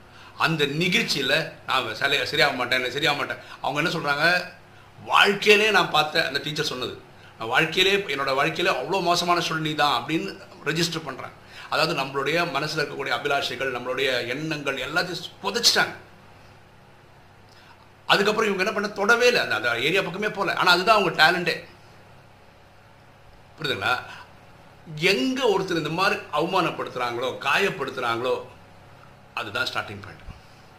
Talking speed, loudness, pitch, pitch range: 120 wpm, -22 LUFS, 155 Hz, 125-190 Hz